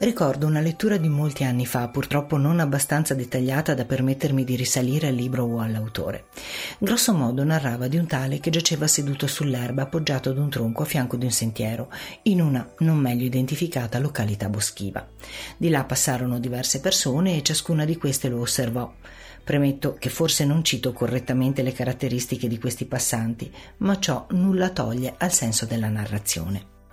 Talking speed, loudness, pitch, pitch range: 165 wpm, -23 LUFS, 130 Hz, 125-155 Hz